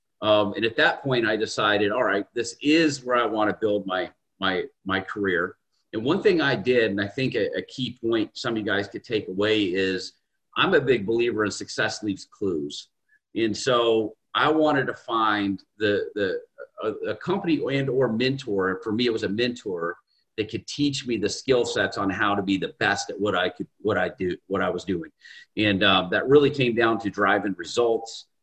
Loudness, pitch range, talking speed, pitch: -24 LUFS, 105-140 Hz, 215 wpm, 115 Hz